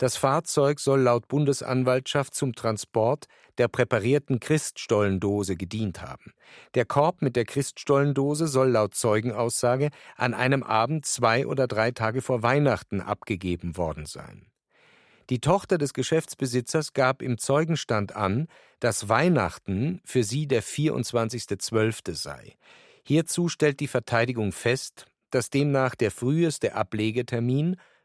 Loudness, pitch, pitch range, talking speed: -25 LUFS, 125 Hz, 110-145 Hz, 120 wpm